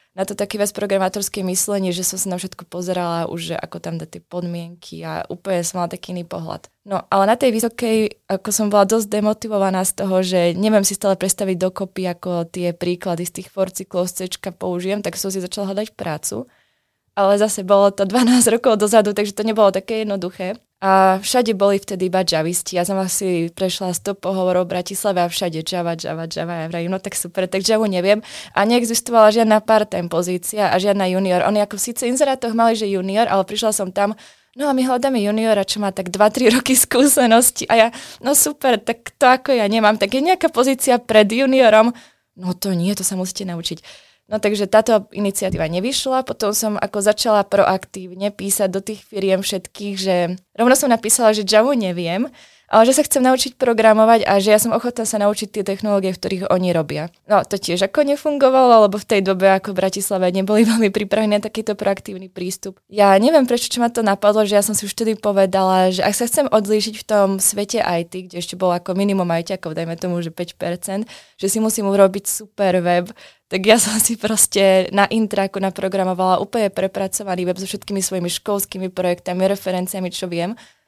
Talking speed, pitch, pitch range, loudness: 195 wpm, 200 Hz, 185-220 Hz, -18 LUFS